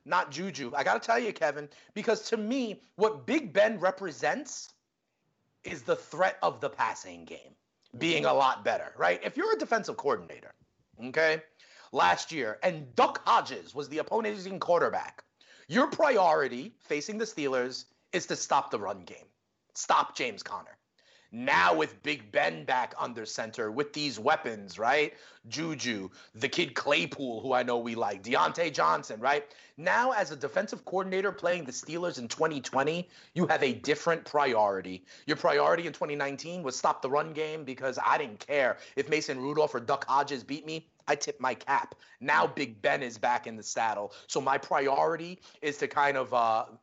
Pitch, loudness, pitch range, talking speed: 155 Hz, -30 LUFS, 130-190 Hz, 175 wpm